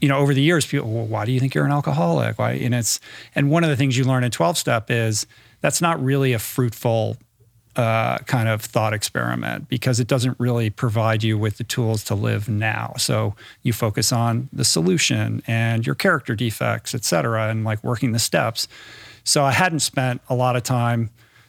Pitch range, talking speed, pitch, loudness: 110-130 Hz, 210 wpm, 120 Hz, -21 LUFS